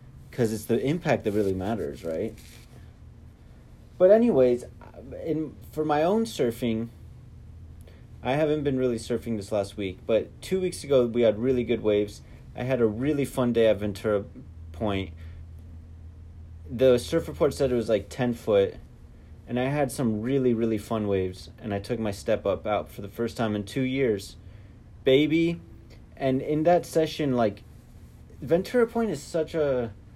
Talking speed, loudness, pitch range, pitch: 165 wpm, -26 LUFS, 105-140 Hz, 115 Hz